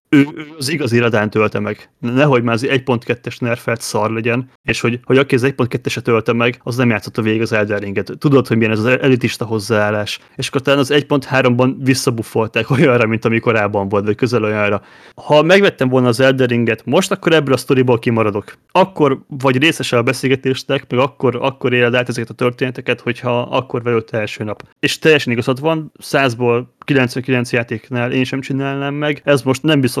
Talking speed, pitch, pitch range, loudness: 190 wpm, 125 Hz, 115-135 Hz, -16 LUFS